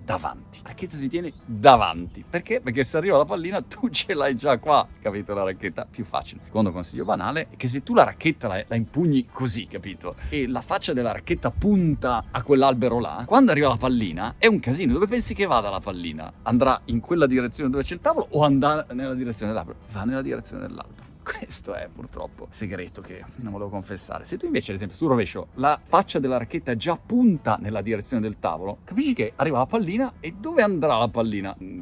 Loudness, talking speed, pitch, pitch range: -23 LUFS, 210 wpm, 125 Hz, 105-160 Hz